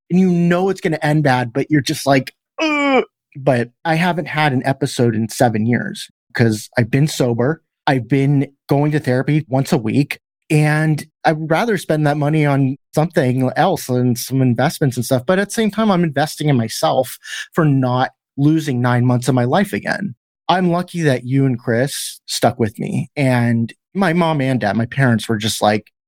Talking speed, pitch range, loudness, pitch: 195 wpm, 125-160 Hz, -17 LUFS, 140 Hz